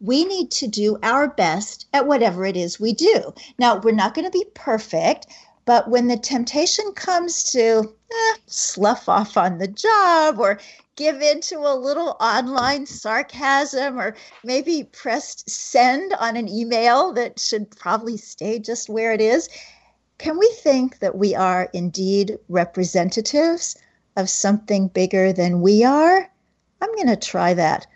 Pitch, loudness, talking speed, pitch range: 235 Hz, -19 LUFS, 155 wpm, 205-295 Hz